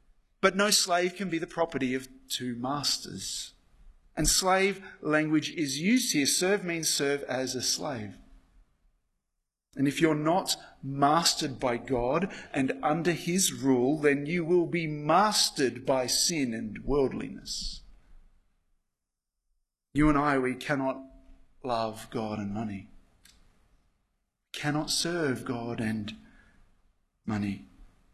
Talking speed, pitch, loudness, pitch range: 120 wpm, 135 Hz, -28 LUFS, 105-155 Hz